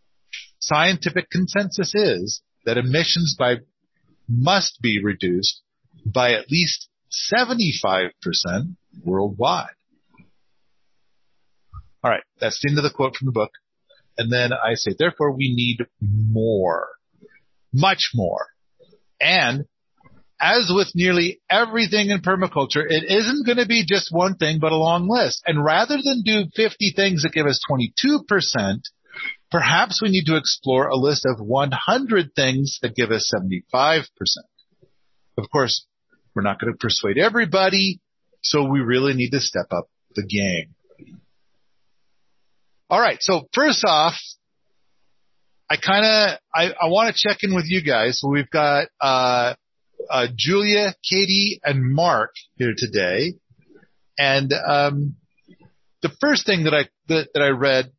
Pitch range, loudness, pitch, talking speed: 125-190 Hz, -20 LUFS, 150 Hz, 140 wpm